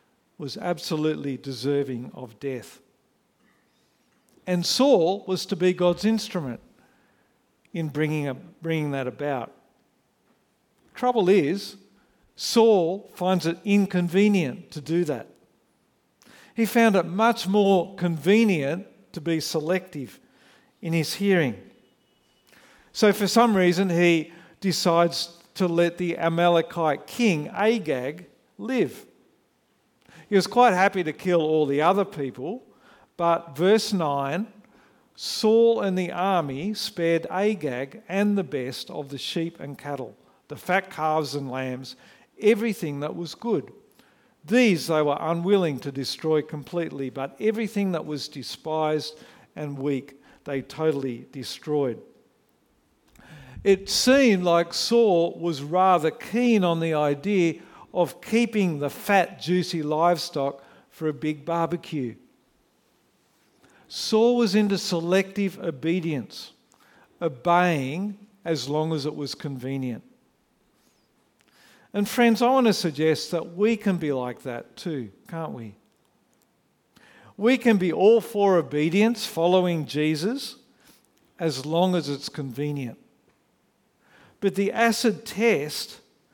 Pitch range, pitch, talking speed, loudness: 150-200 Hz, 170 Hz, 115 wpm, -24 LUFS